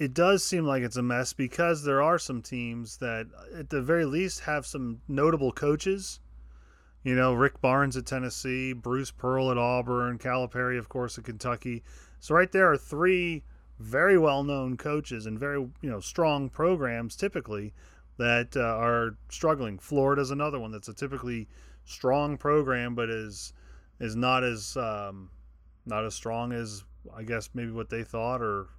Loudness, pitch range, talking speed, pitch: -28 LUFS, 115-140 Hz, 170 wpm, 125 Hz